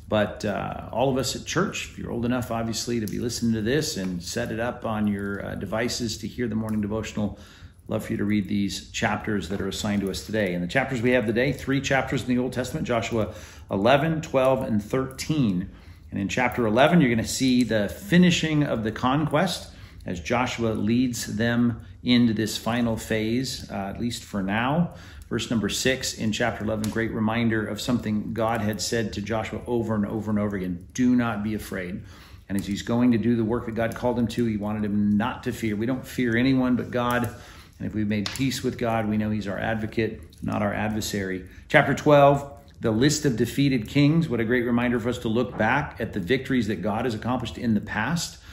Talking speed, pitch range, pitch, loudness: 220 wpm, 105-125 Hz, 115 Hz, -25 LUFS